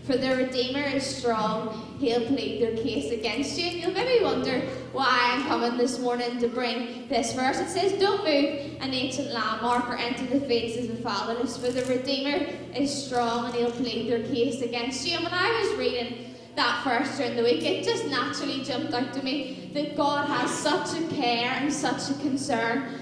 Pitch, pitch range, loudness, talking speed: 255 Hz, 240-285 Hz, -27 LUFS, 200 wpm